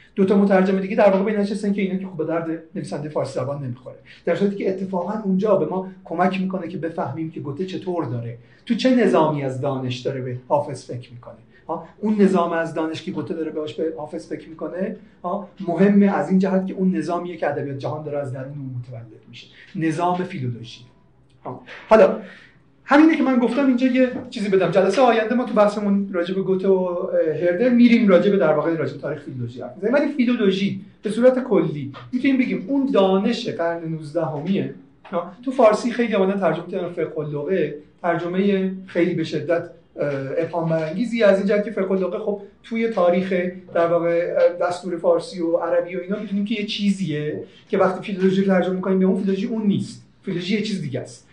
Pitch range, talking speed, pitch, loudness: 160-200 Hz, 185 wpm, 185 Hz, -21 LUFS